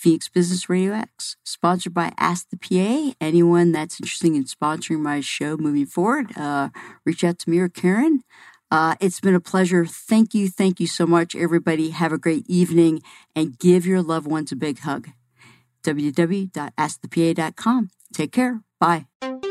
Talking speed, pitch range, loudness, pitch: 165 wpm, 155-185 Hz, -21 LUFS, 170 Hz